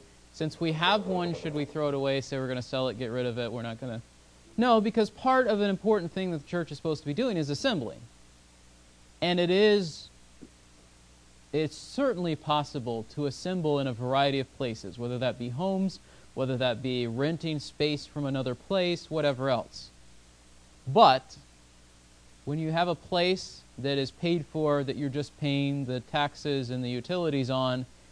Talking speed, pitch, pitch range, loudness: 185 wpm, 140 Hz, 120-160 Hz, -29 LUFS